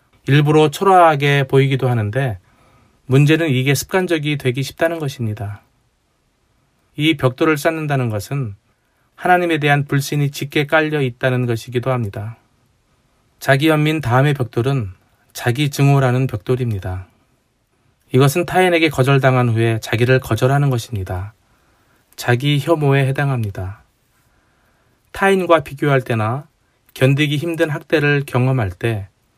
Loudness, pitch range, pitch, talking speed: -17 LUFS, 120-150 Hz, 130 Hz, 285 characters per minute